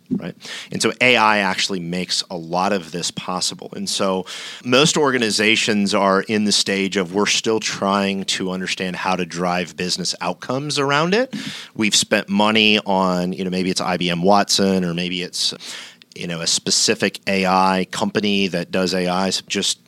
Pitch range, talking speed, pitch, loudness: 90-105 Hz, 170 wpm, 95 Hz, -18 LUFS